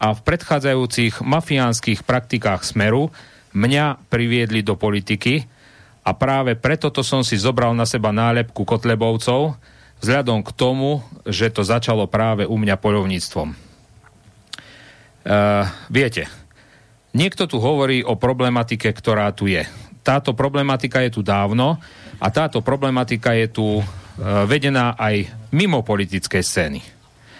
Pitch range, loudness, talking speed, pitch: 105-130 Hz, -19 LUFS, 125 wpm, 115 Hz